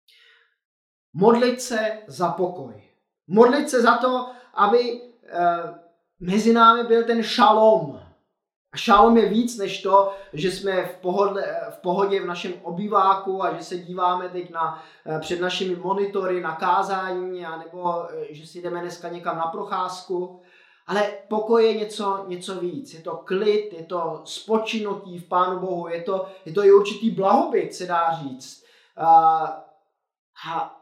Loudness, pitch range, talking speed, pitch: -22 LUFS, 175-210 Hz, 145 wpm, 190 Hz